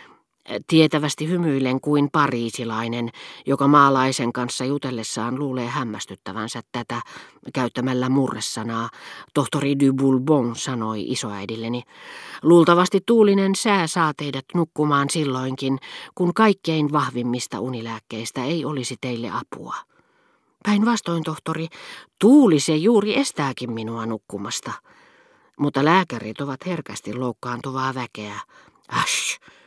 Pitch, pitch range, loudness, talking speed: 135 Hz, 120-160 Hz, -21 LUFS, 95 wpm